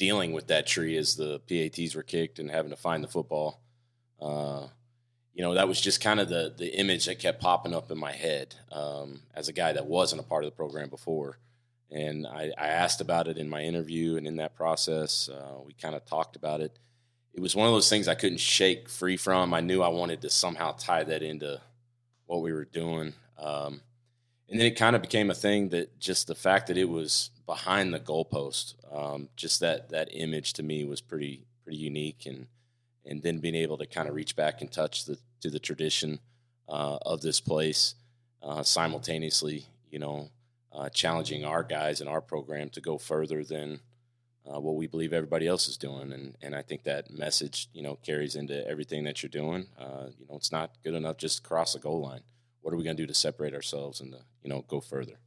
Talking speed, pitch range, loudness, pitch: 220 wpm, 75-95 Hz, -30 LUFS, 80 Hz